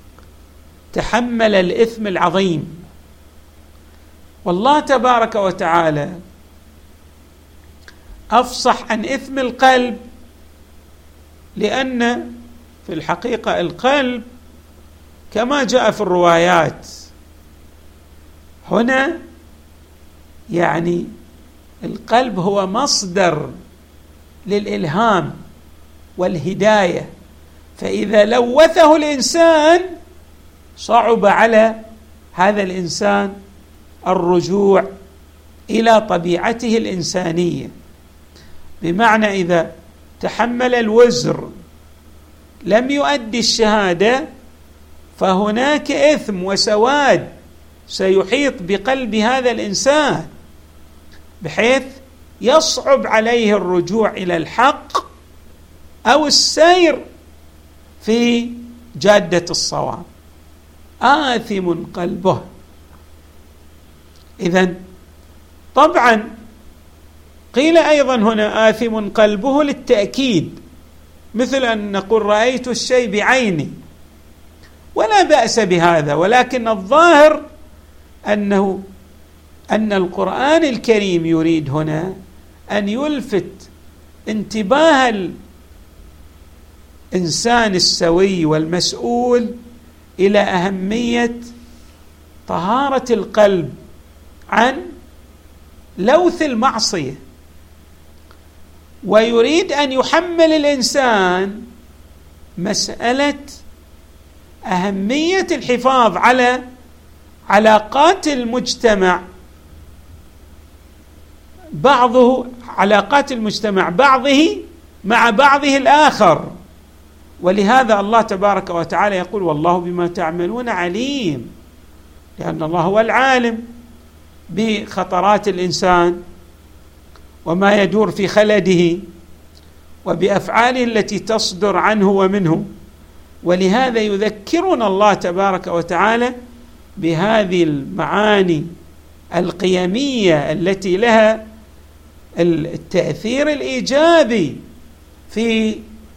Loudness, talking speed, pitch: -15 LUFS, 65 wpm, 185 Hz